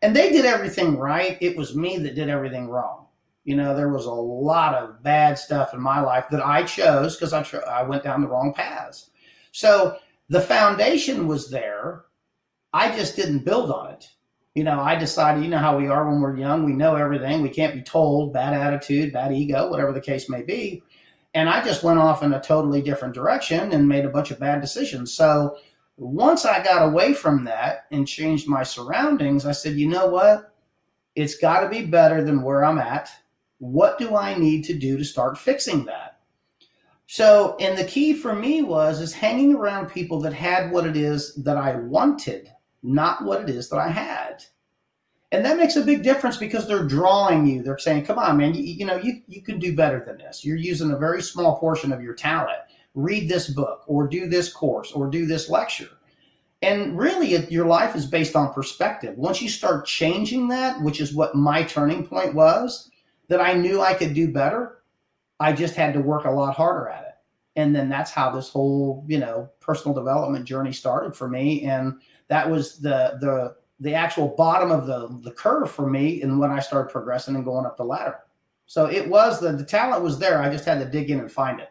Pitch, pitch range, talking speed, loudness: 150 Hz, 140-180 Hz, 210 wpm, -21 LUFS